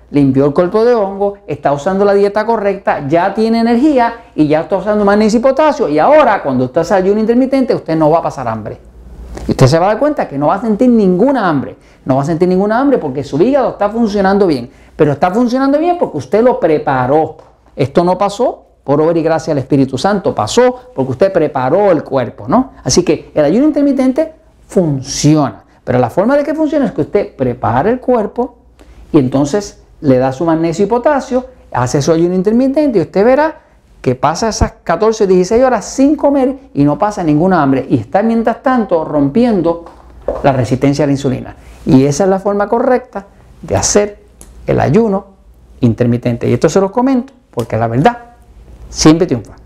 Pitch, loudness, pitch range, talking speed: 195 Hz, -12 LUFS, 145-240 Hz, 195 wpm